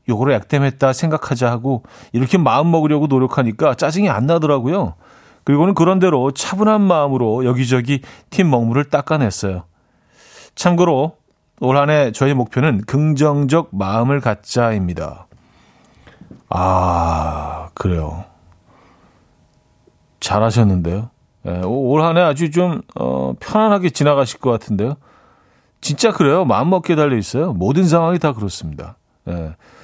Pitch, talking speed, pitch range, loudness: 135 Hz, 285 characters per minute, 105-155 Hz, -16 LUFS